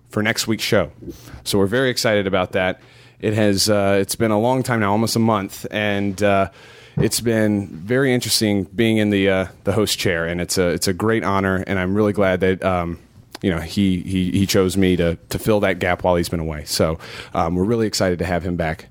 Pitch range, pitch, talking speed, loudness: 90-110 Hz, 100 Hz, 225 wpm, -19 LUFS